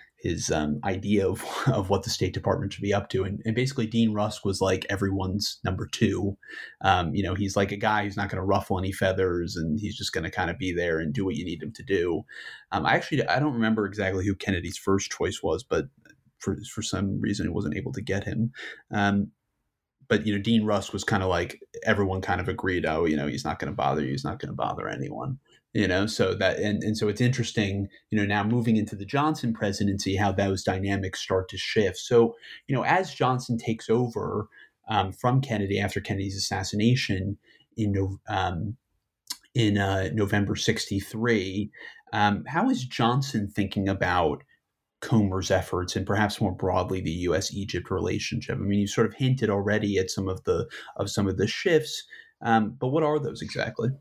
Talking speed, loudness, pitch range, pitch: 205 wpm, -27 LUFS, 95-110 Hz, 100 Hz